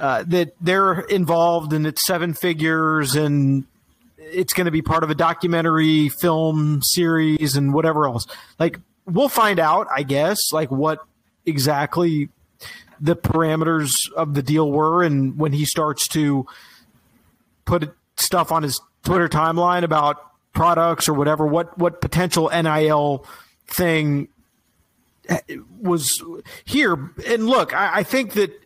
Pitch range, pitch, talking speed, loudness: 150-175 Hz, 160 Hz, 135 wpm, -19 LUFS